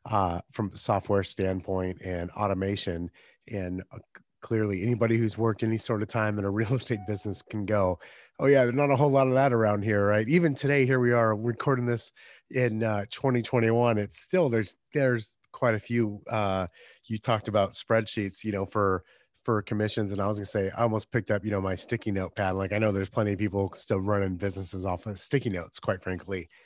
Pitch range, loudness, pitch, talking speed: 100-115 Hz, -28 LUFS, 105 Hz, 215 wpm